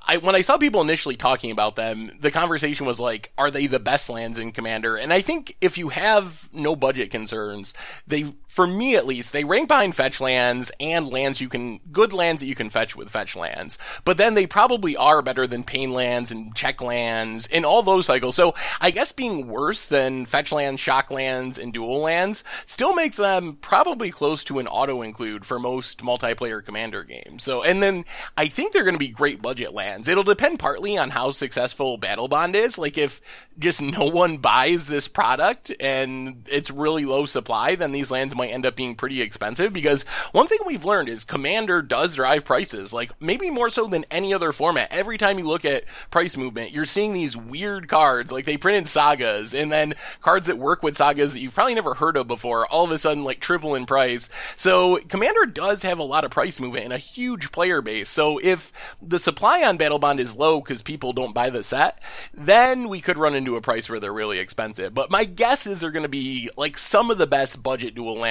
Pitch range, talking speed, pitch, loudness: 130-185 Hz, 220 wpm, 145 Hz, -22 LUFS